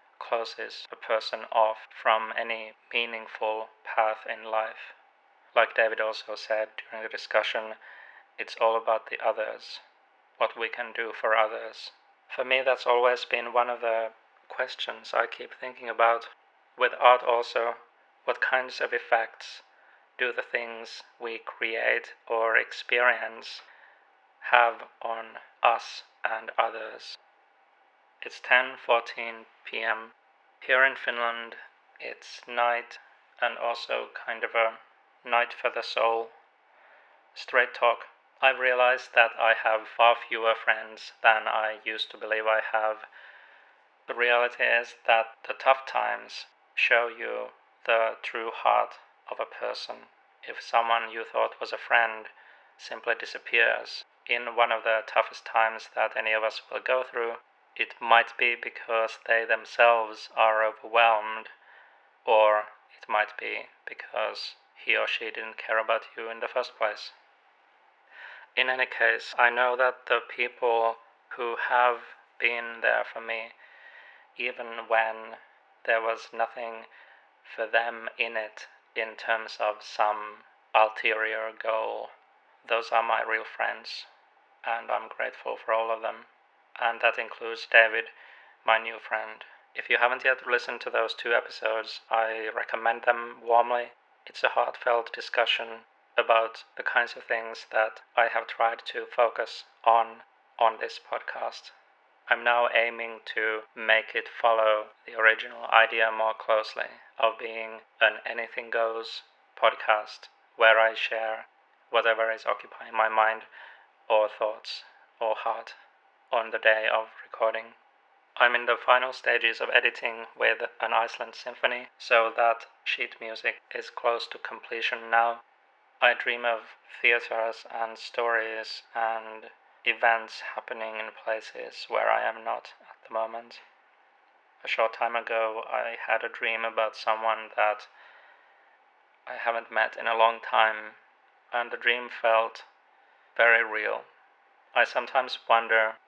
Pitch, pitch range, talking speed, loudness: 115 Hz, 110-115 Hz, 140 wpm, -27 LUFS